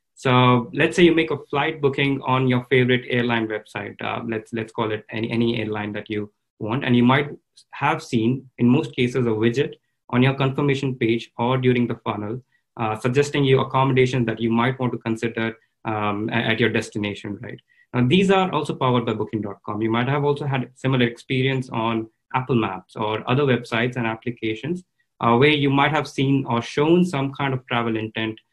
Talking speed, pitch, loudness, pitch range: 195 wpm, 125 Hz, -21 LUFS, 115-135 Hz